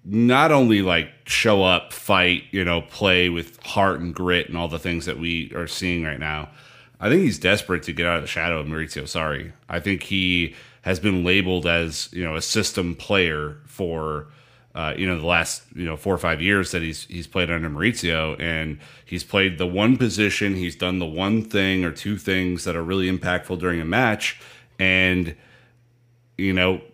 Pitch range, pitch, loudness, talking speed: 85-95 Hz, 90 Hz, -22 LUFS, 200 wpm